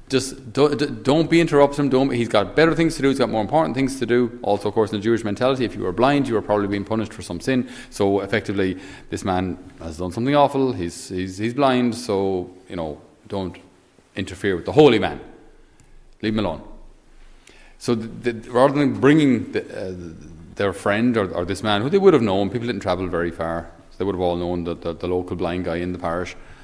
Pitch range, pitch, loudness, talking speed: 90-130 Hz, 105 Hz, -21 LUFS, 230 wpm